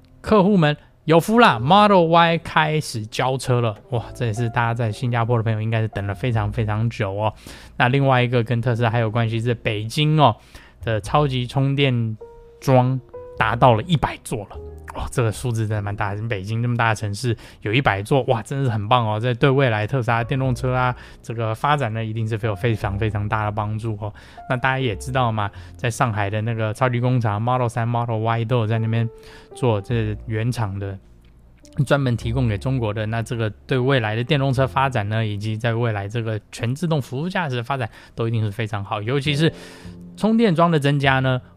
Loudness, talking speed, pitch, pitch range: -21 LUFS, 320 characters per minute, 120 Hz, 110-130 Hz